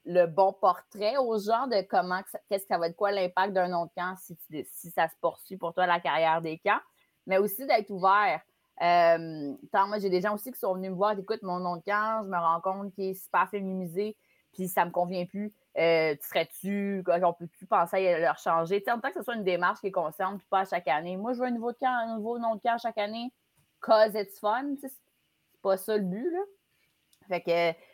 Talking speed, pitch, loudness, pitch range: 245 wpm, 195 Hz, -29 LUFS, 175-215 Hz